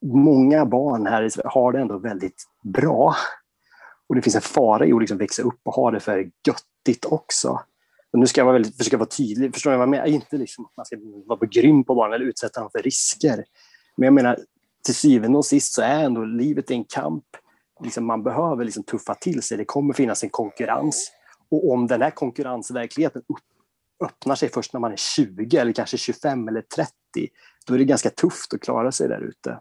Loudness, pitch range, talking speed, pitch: -21 LUFS, 120-145 Hz, 215 wpm, 135 Hz